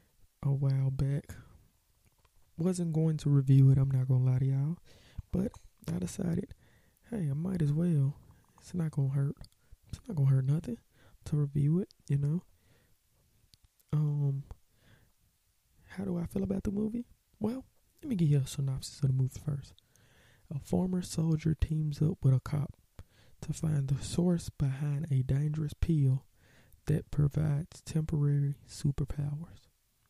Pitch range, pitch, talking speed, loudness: 130-160 Hz, 145 Hz, 150 wpm, -32 LUFS